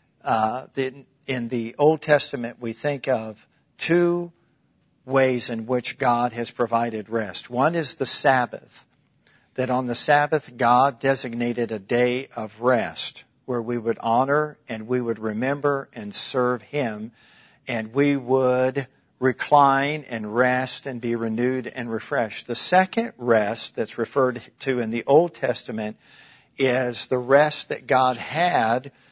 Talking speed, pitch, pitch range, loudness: 140 wpm, 125 Hz, 115-140 Hz, -23 LUFS